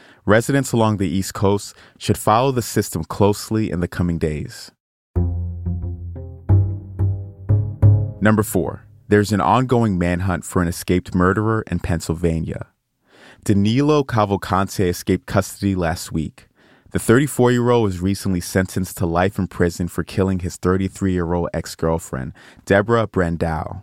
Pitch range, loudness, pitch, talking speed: 85-105 Hz, -20 LUFS, 95 Hz, 120 wpm